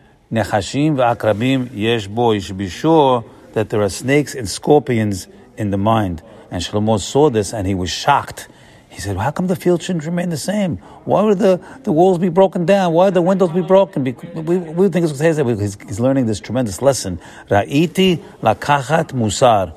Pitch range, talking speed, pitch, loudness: 110-175 Hz, 180 wpm, 130 Hz, -17 LUFS